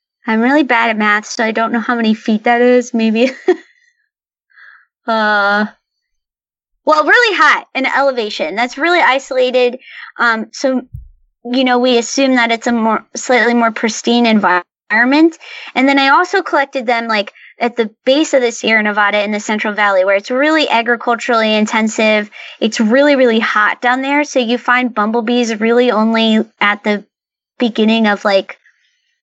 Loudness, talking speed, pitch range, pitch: -13 LUFS, 160 wpm, 220-270 Hz, 240 Hz